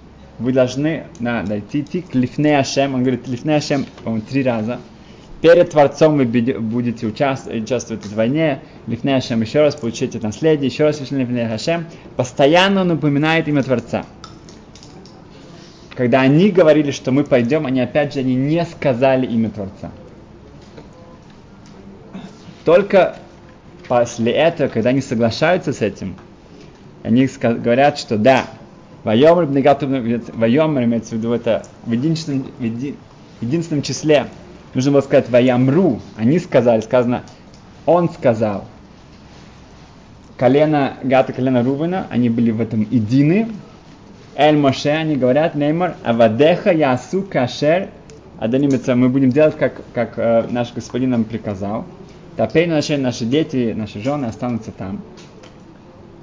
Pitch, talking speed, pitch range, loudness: 130 Hz, 125 wpm, 115-150 Hz, -17 LUFS